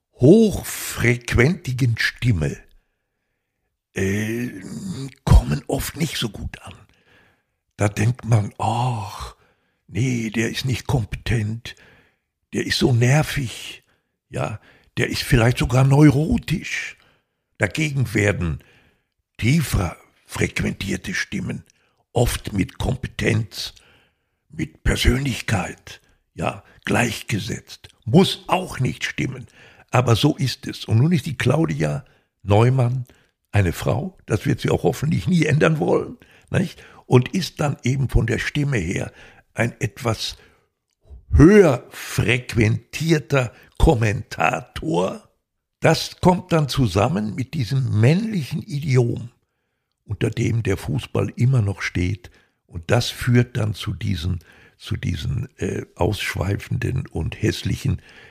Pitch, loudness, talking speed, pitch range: 120 Hz, -21 LUFS, 110 wpm, 105-135 Hz